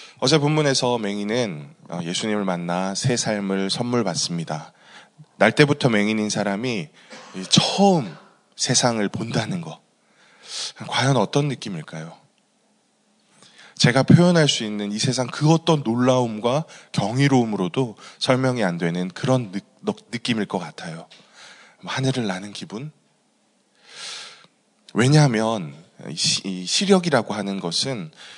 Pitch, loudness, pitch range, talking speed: 120 Hz, -21 LUFS, 100-140 Hz, 240 characters per minute